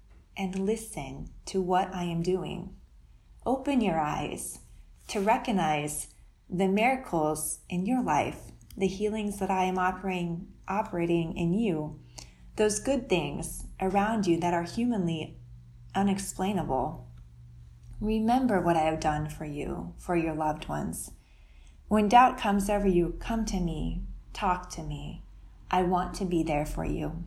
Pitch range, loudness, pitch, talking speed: 150-200 Hz, -29 LUFS, 175 Hz, 140 wpm